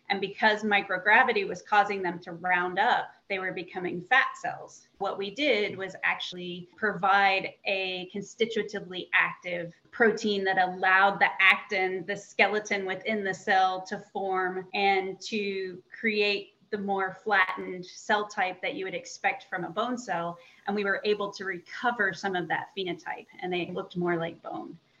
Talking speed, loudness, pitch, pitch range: 160 wpm, -27 LUFS, 195 Hz, 185-205 Hz